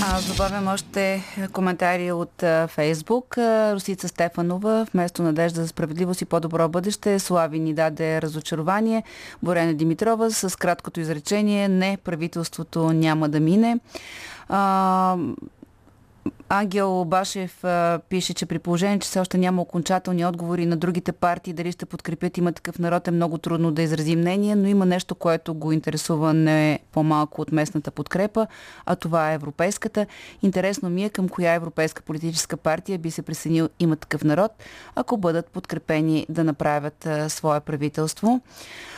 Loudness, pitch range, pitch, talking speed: -23 LUFS, 160-190 Hz, 175 Hz, 145 wpm